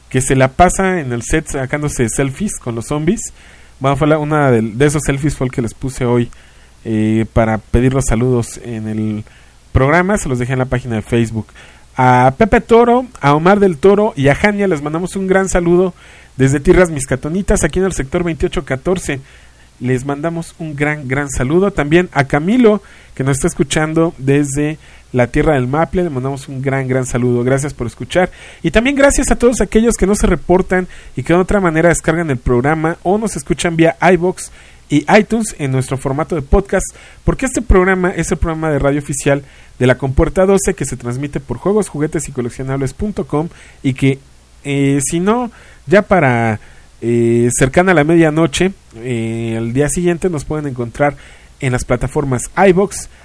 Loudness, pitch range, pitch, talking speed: -14 LUFS, 130-180 Hz, 150 Hz, 185 wpm